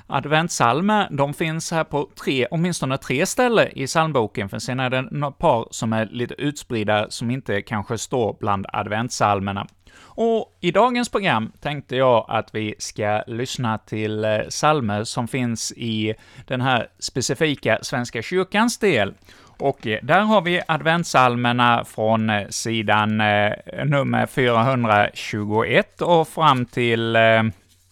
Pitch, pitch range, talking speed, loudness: 120 Hz, 110-145 Hz, 135 wpm, -21 LUFS